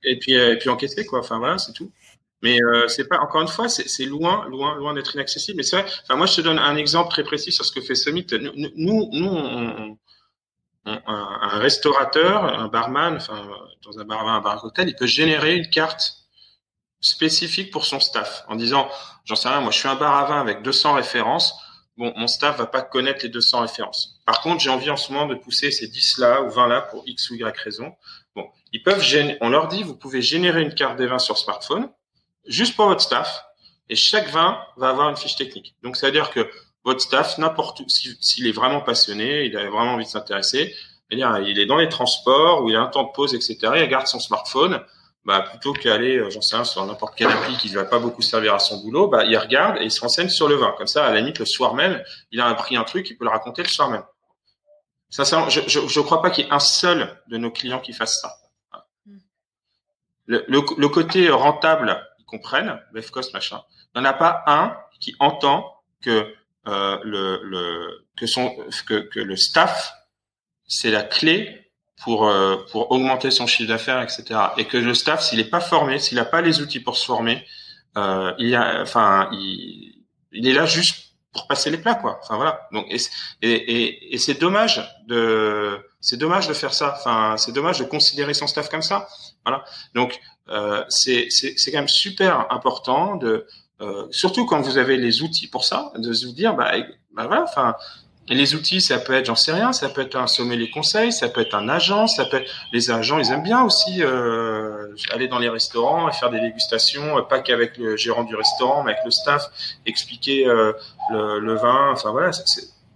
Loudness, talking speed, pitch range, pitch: -19 LUFS, 225 wpm, 115-155 Hz, 130 Hz